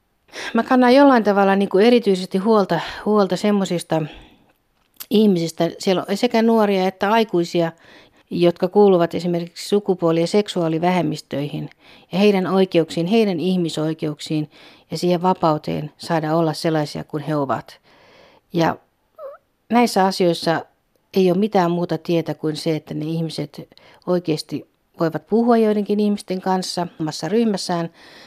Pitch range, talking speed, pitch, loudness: 165-205 Hz, 125 wpm, 180 Hz, -19 LUFS